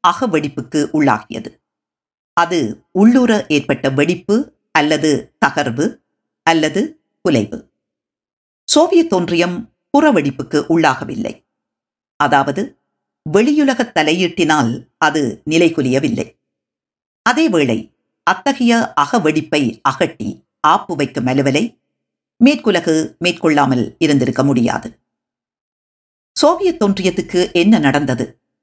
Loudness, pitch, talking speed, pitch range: -15 LUFS, 160 Hz, 75 wpm, 145-215 Hz